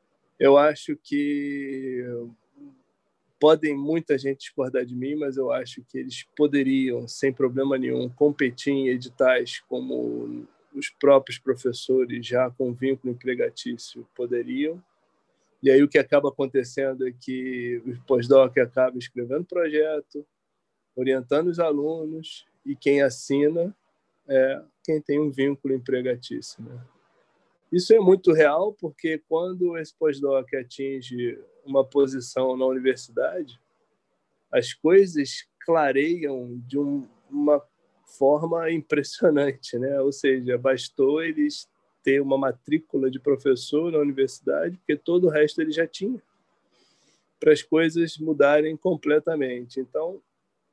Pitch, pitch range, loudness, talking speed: 140 Hz, 130-155 Hz, -24 LUFS, 120 wpm